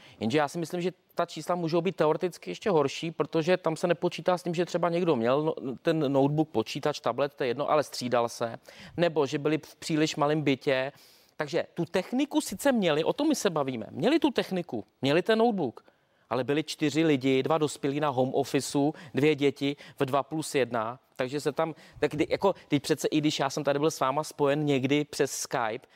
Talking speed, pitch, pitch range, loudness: 205 wpm, 155 Hz, 140-175 Hz, -28 LUFS